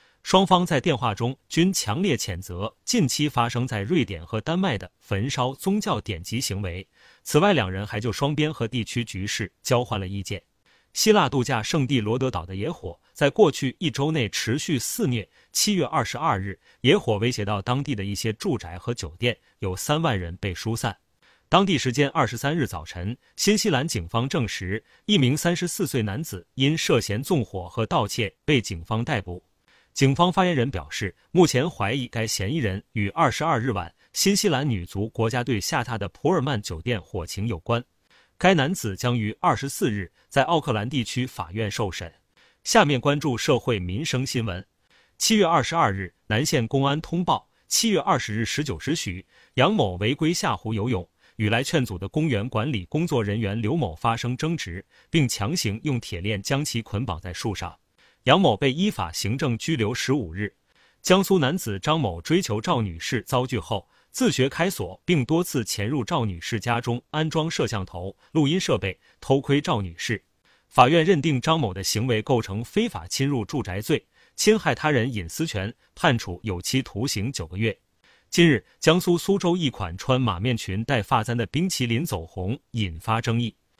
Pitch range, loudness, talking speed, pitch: 105-150 Hz, -24 LUFS, 270 characters per minute, 120 Hz